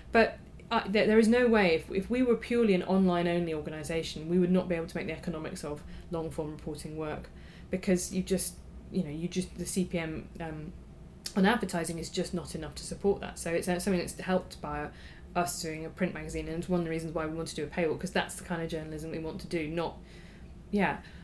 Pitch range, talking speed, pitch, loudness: 160-185 Hz, 230 wpm, 175 Hz, -31 LUFS